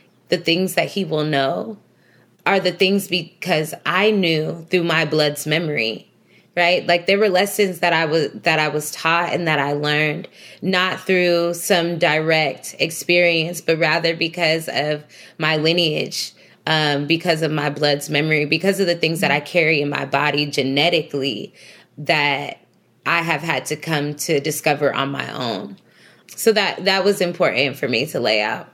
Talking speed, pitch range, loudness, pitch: 170 wpm, 150-175 Hz, -19 LUFS, 165 Hz